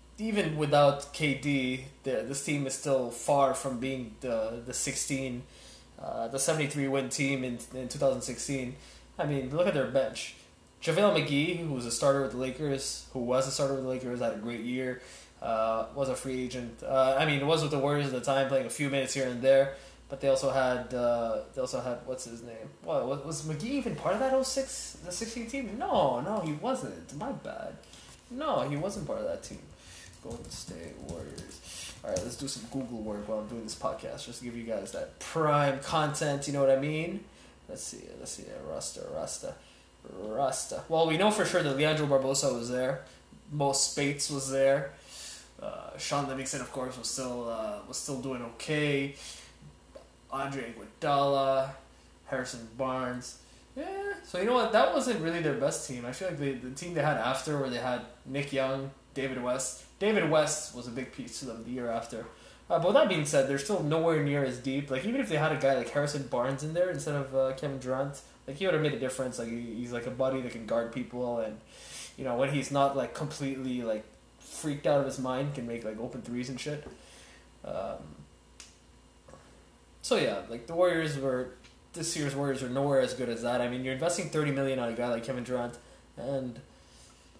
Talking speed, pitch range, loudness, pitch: 210 wpm, 125-145 Hz, -31 LUFS, 135 Hz